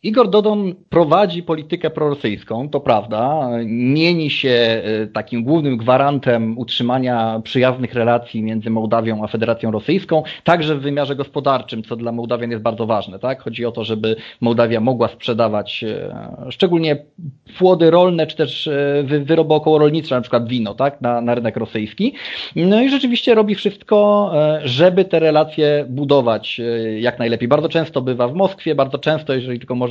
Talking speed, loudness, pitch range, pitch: 155 wpm, -17 LUFS, 115-160 Hz, 135 Hz